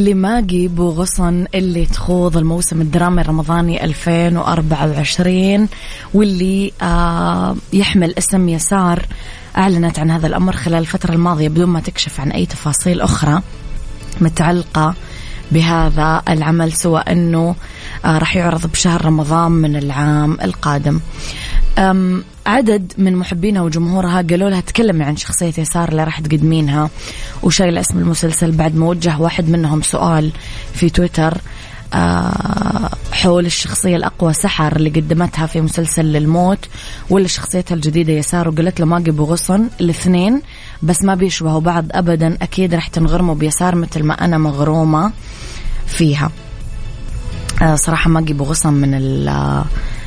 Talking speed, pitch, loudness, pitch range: 130 wpm, 165 Hz, -15 LUFS, 155-180 Hz